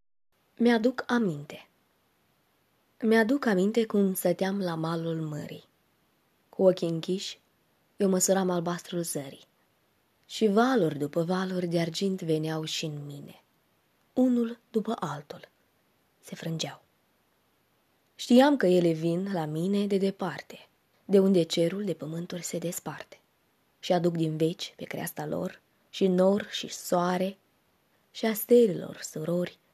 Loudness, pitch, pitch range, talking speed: -28 LUFS, 180 Hz, 165-205 Hz, 125 wpm